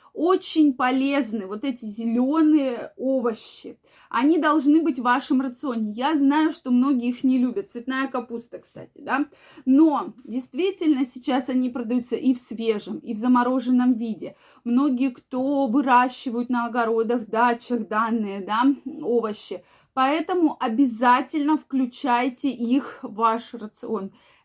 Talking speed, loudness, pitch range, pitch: 125 wpm, -23 LUFS, 240-280 Hz, 255 Hz